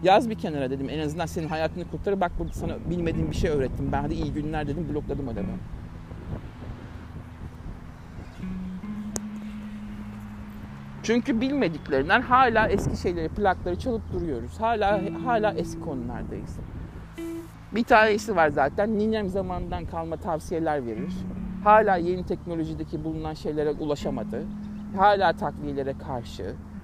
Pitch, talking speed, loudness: 160 Hz, 120 wpm, -26 LUFS